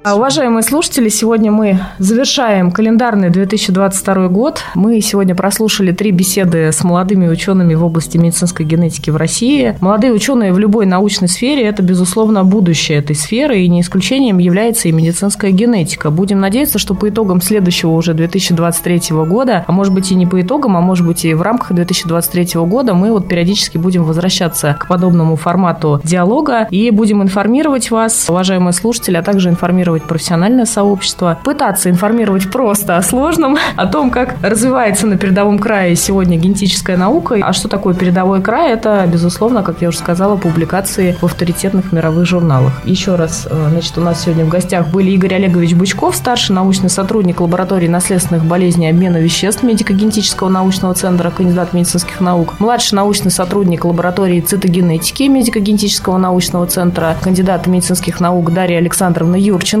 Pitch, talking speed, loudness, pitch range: 185 Hz, 155 wpm, -12 LUFS, 175-210 Hz